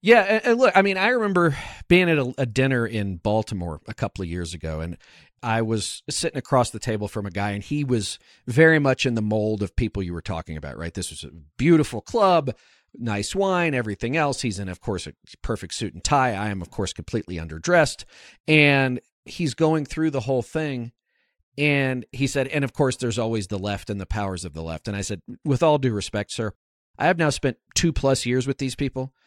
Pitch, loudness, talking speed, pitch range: 120 Hz, -23 LUFS, 220 wpm, 100-145 Hz